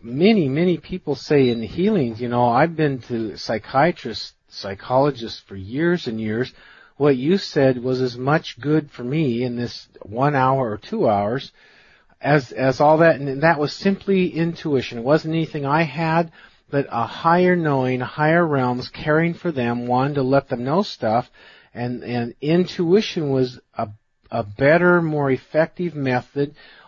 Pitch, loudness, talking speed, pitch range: 140 Hz, -20 LUFS, 165 wpm, 125-165 Hz